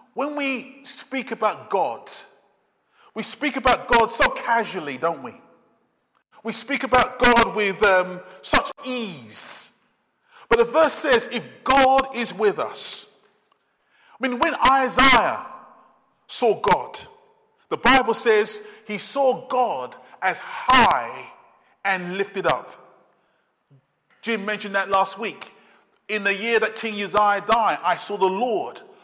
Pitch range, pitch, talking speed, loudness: 205-265 Hz, 230 Hz, 130 wpm, -21 LUFS